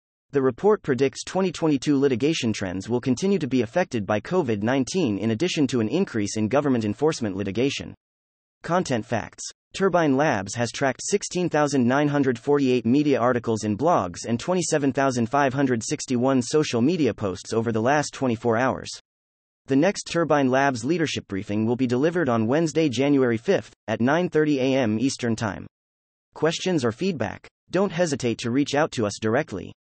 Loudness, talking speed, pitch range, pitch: -23 LUFS, 145 wpm, 110-150 Hz, 130 Hz